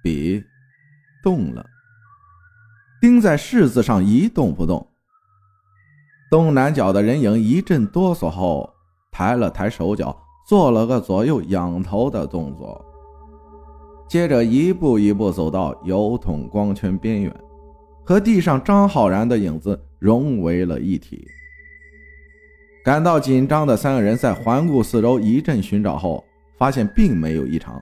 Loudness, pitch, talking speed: -18 LUFS, 115 Hz, 195 characters per minute